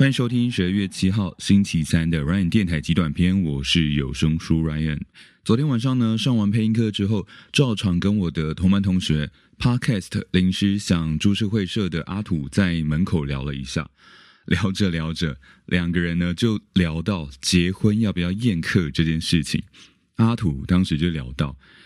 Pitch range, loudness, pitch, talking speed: 80-105 Hz, -22 LUFS, 90 Hz, 290 characters per minute